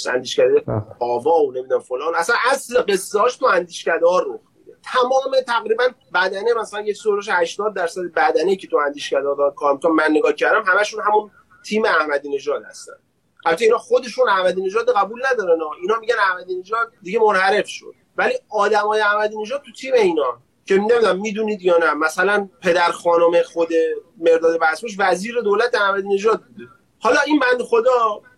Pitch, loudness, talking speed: 255 Hz, -18 LUFS, 165 wpm